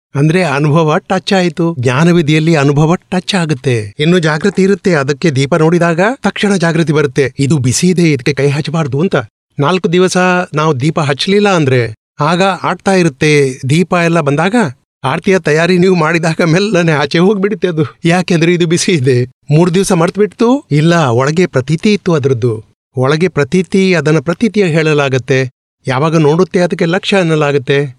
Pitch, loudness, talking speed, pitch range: 165 Hz, -11 LUFS, 140 wpm, 145-185 Hz